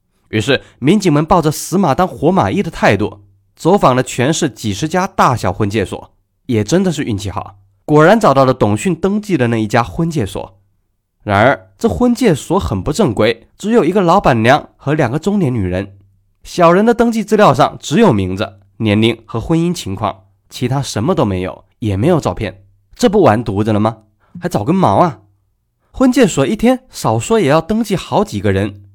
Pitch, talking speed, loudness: 120 Hz, 280 characters per minute, -14 LUFS